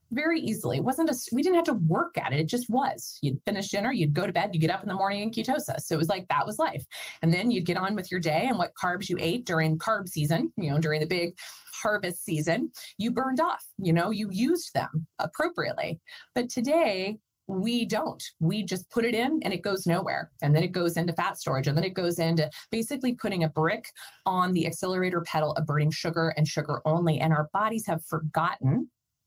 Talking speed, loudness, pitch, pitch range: 235 wpm, -28 LUFS, 180 Hz, 160-225 Hz